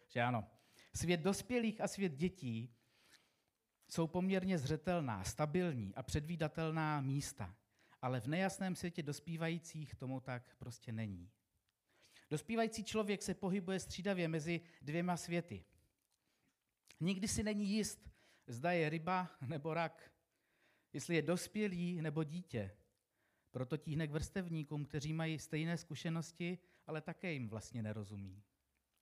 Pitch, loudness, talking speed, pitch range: 160 Hz, -41 LUFS, 120 wpm, 120-175 Hz